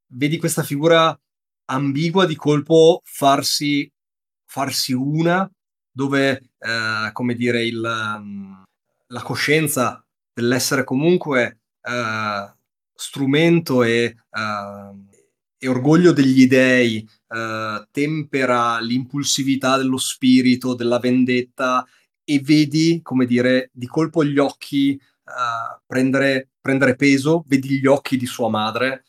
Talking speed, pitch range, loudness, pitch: 105 wpm, 120-145 Hz, -18 LUFS, 130 Hz